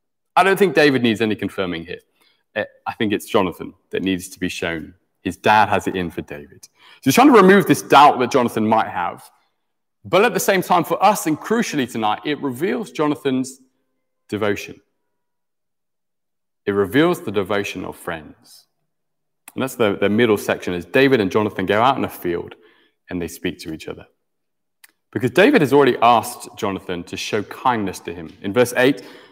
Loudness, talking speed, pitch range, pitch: -18 LUFS, 185 wpm, 95-140 Hz, 110 Hz